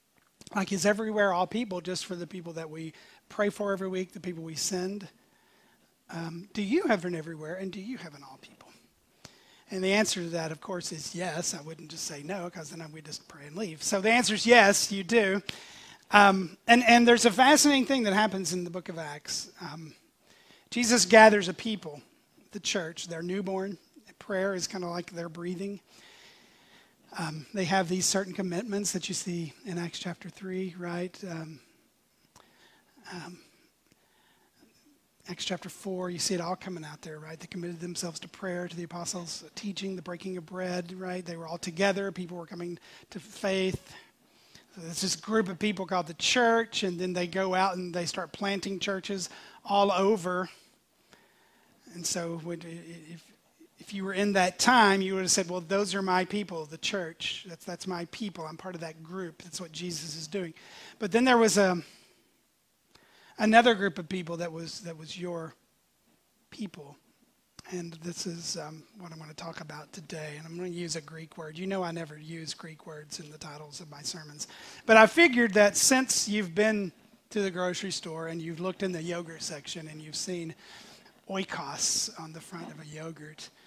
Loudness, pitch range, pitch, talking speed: -28 LUFS, 165-200 Hz, 180 Hz, 195 wpm